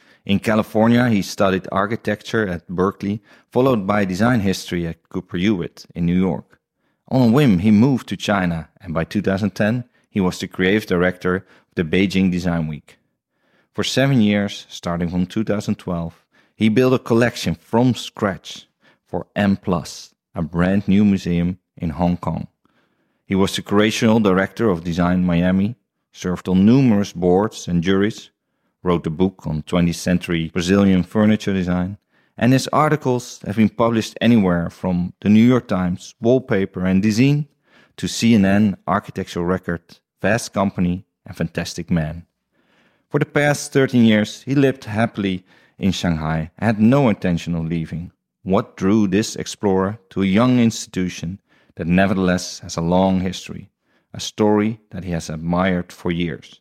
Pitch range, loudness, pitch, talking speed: 90-110 Hz, -19 LUFS, 95 Hz, 150 wpm